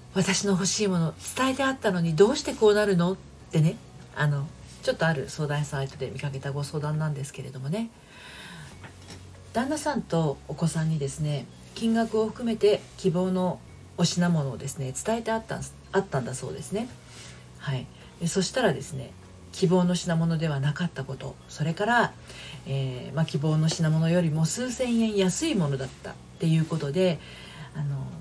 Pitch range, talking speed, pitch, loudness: 140-195 Hz, 340 characters per minute, 165 Hz, -27 LUFS